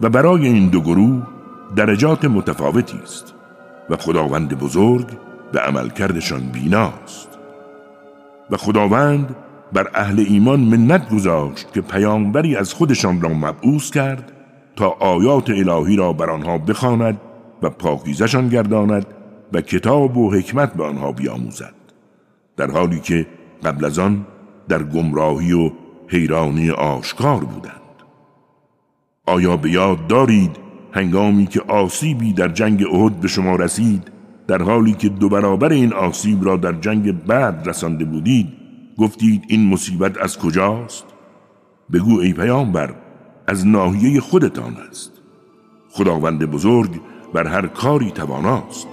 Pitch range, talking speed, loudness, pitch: 85-115 Hz, 125 wpm, -17 LUFS, 100 Hz